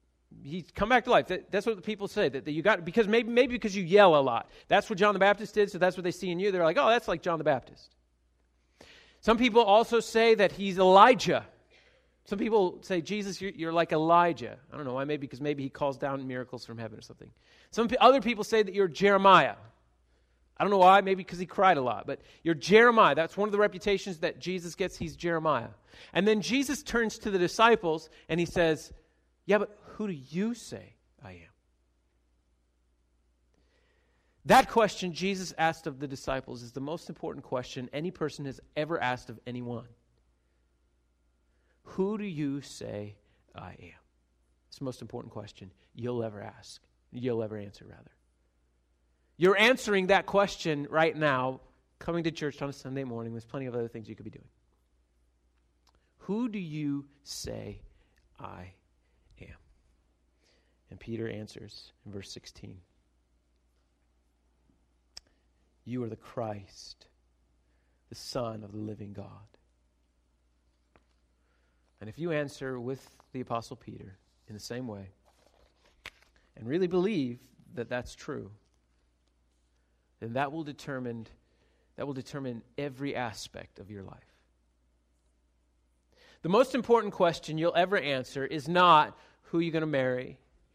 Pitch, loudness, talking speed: 125 Hz, -28 LUFS, 160 wpm